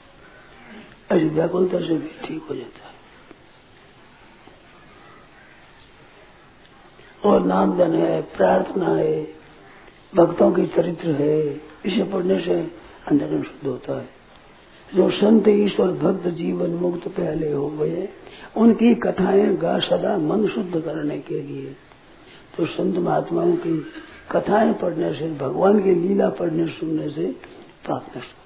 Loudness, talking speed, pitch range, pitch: -21 LUFS, 120 wpm, 160-200 Hz, 175 Hz